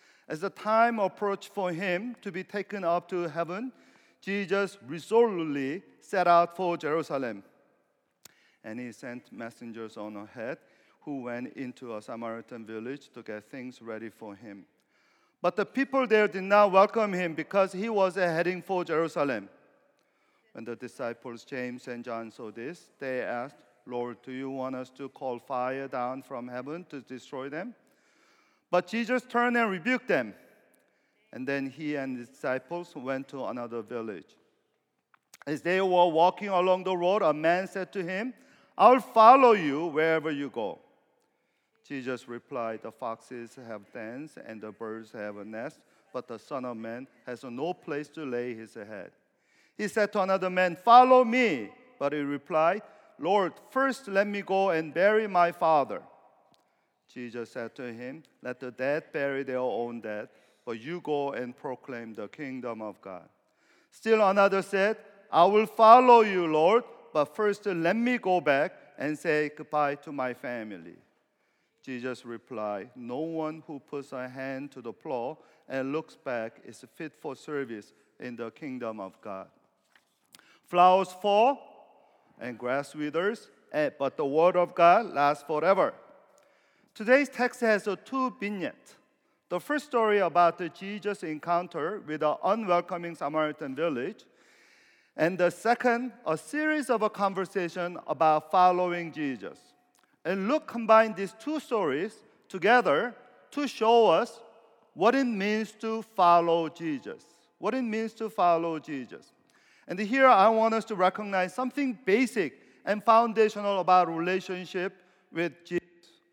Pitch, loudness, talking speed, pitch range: 175 Hz, -27 LUFS, 150 wpm, 135-205 Hz